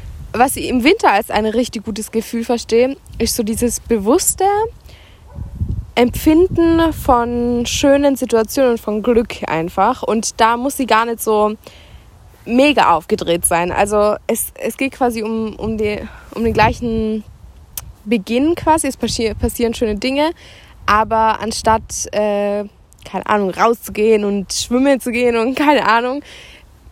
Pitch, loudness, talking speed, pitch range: 230 Hz, -16 LUFS, 140 wpm, 215-255 Hz